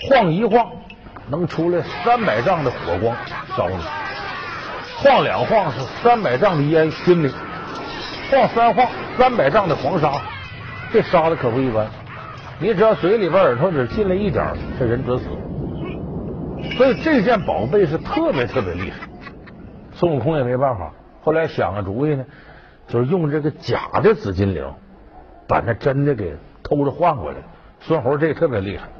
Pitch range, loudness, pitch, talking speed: 125-195 Hz, -19 LUFS, 155 Hz, 235 characters per minute